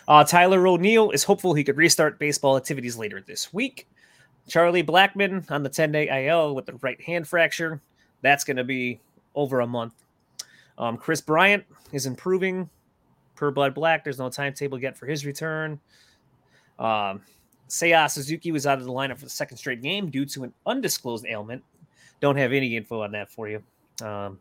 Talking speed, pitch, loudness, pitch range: 180 wpm, 140 Hz, -23 LUFS, 125-160 Hz